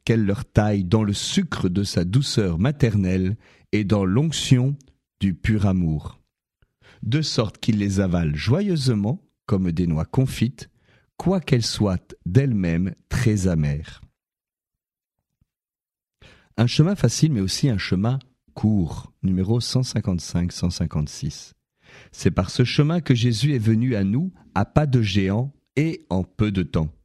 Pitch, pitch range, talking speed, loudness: 110 Hz, 95-130 Hz, 135 wpm, -22 LUFS